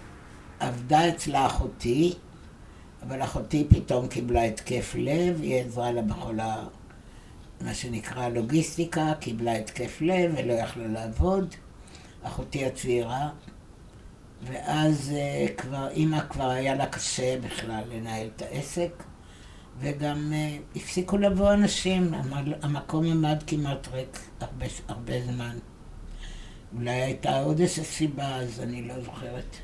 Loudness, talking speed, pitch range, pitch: -28 LUFS, 110 wpm, 120-155 Hz, 130 Hz